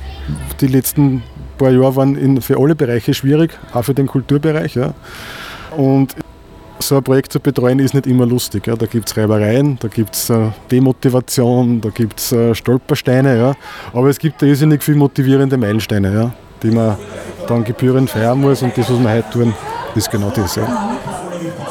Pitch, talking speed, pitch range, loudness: 125 Hz, 170 wpm, 115-140 Hz, -15 LUFS